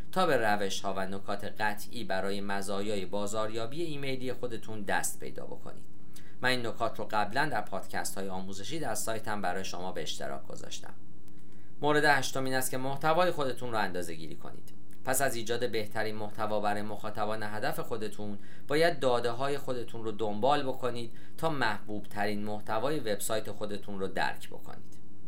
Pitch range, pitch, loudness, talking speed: 100-120 Hz, 105 Hz, -33 LUFS, 160 wpm